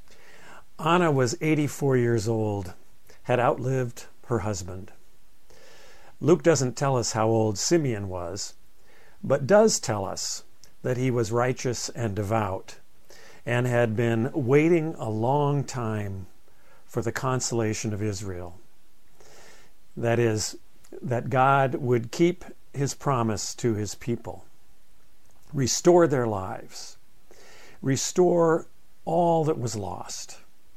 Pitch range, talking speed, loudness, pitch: 110-140 Hz, 115 wpm, -25 LUFS, 120 Hz